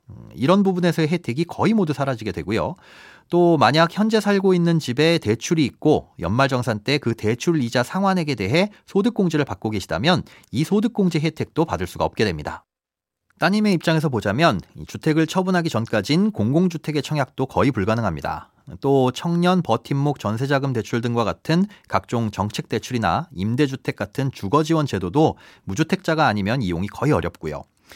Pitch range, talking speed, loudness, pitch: 110-170 Hz, 370 characters per minute, -21 LUFS, 145 Hz